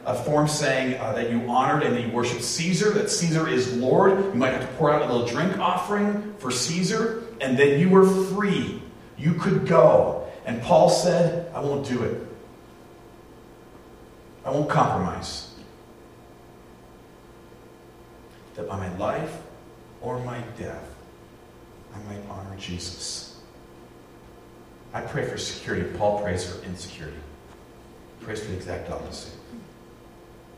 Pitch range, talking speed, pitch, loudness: 115-170 Hz, 140 wpm, 125 Hz, -23 LUFS